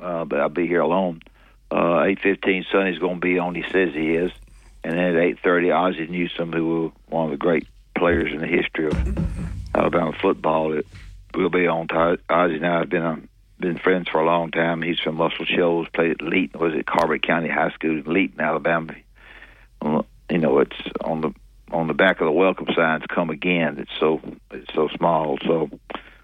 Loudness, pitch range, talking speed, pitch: -22 LUFS, 80-90 Hz, 205 wpm, 85 Hz